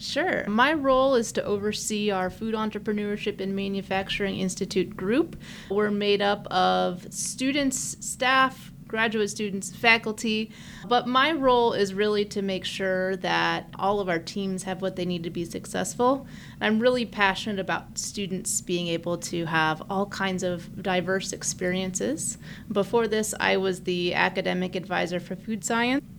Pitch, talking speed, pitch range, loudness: 195 Hz, 150 wpm, 185-220 Hz, -26 LUFS